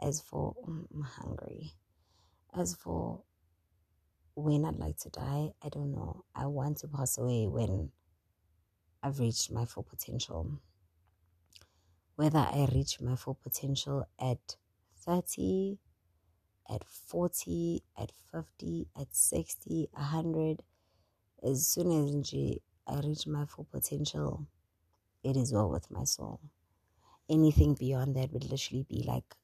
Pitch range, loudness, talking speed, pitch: 85-140 Hz, -34 LUFS, 125 wpm, 105 Hz